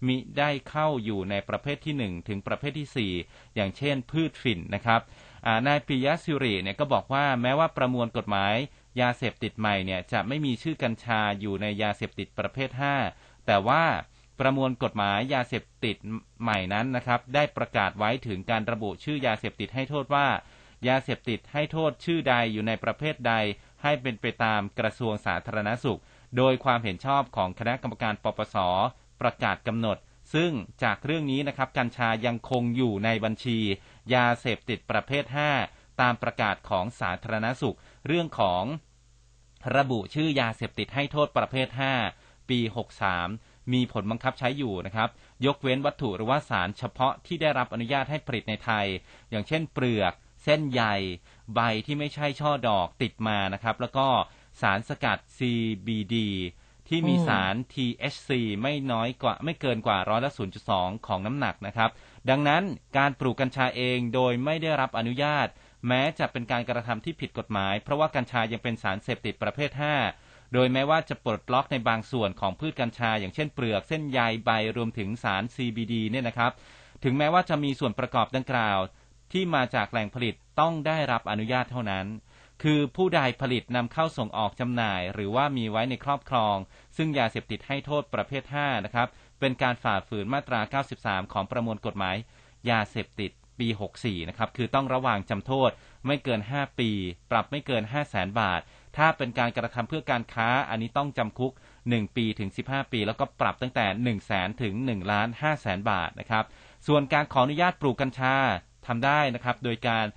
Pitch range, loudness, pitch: 110-135 Hz, -28 LUFS, 120 Hz